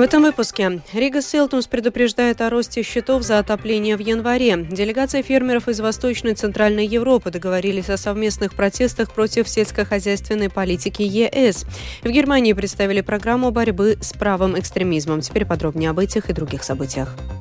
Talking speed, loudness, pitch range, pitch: 150 wpm, -19 LUFS, 195-240 Hz, 215 Hz